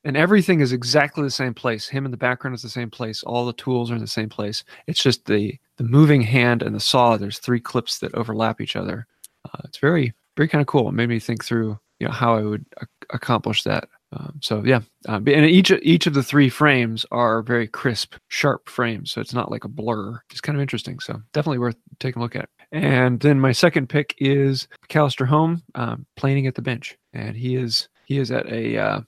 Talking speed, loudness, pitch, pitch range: 235 wpm, -21 LUFS, 130 Hz, 115-145 Hz